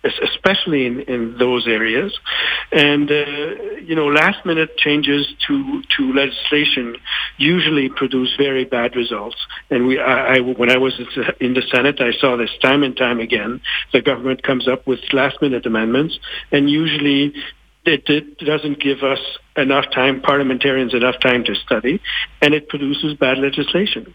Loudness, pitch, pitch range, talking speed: -17 LUFS, 140 Hz, 130-150 Hz, 160 wpm